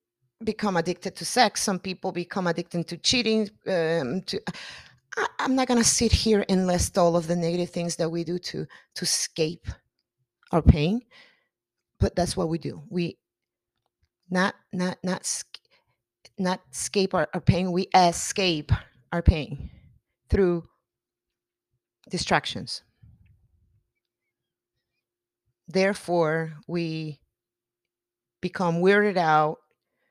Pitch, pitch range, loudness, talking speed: 175 Hz, 130-185 Hz, -25 LUFS, 120 wpm